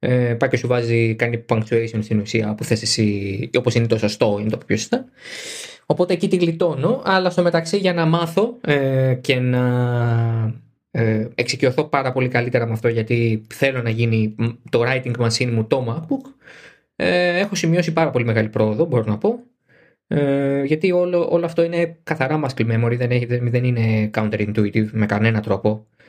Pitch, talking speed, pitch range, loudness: 125 Hz, 170 wpm, 115-165 Hz, -19 LUFS